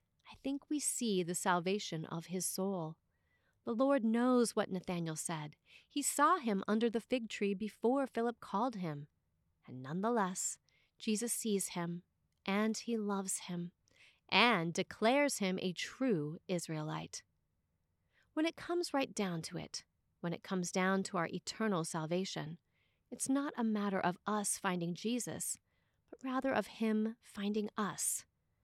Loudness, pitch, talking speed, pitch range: -36 LUFS, 200 Hz, 145 wpm, 175-235 Hz